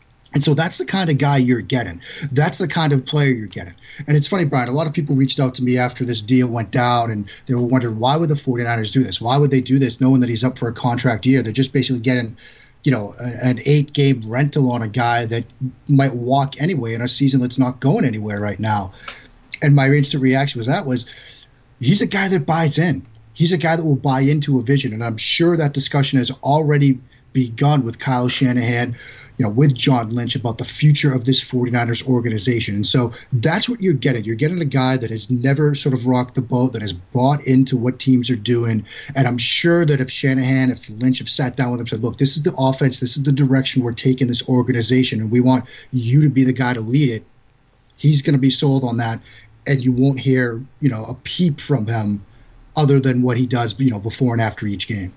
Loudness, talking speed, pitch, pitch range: -18 LUFS, 240 wpm, 130 Hz, 120-140 Hz